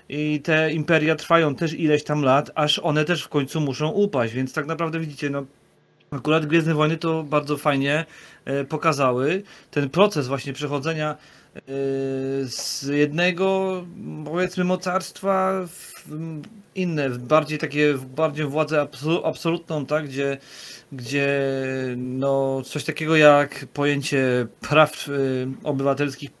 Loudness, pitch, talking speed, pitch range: -22 LUFS, 150 Hz, 125 wpm, 140-160 Hz